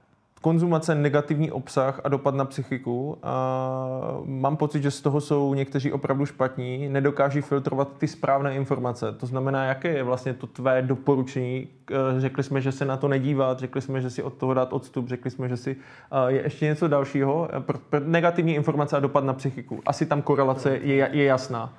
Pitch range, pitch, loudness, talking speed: 130-145 Hz, 135 Hz, -25 LUFS, 175 wpm